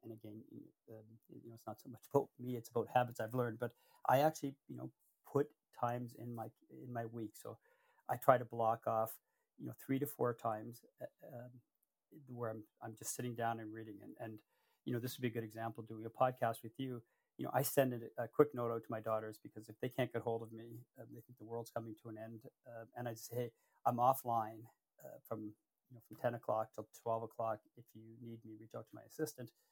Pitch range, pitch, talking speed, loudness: 110-125 Hz, 115 Hz, 235 wpm, -41 LUFS